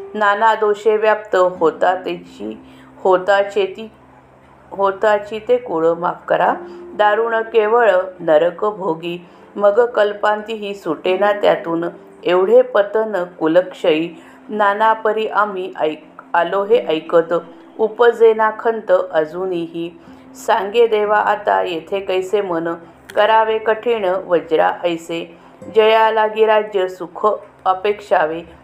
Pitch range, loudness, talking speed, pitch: 170-220 Hz, -17 LUFS, 100 wpm, 200 Hz